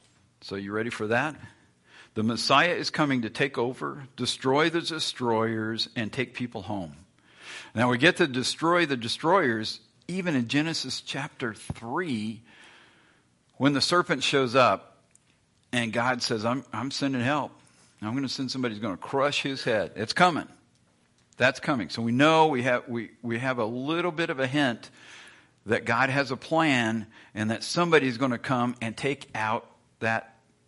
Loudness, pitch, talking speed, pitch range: -26 LUFS, 125 Hz, 170 wpm, 115-140 Hz